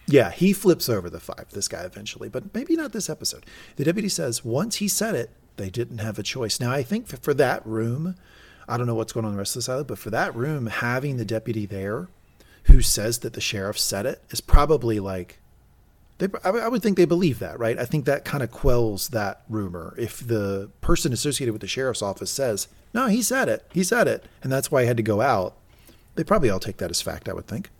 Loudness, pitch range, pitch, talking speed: -24 LUFS, 110-165 Hz, 120 Hz, 240 wpm